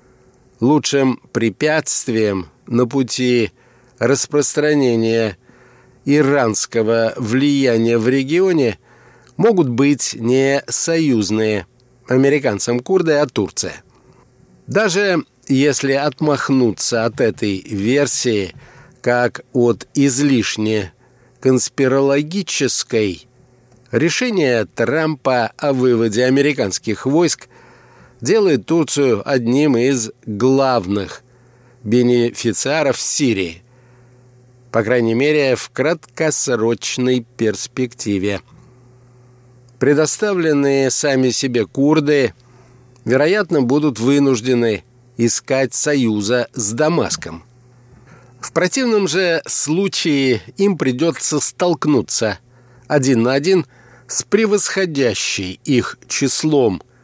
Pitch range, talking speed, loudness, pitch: 120-145 Hz, 75 wpm, -17 LUFS, 125 Hz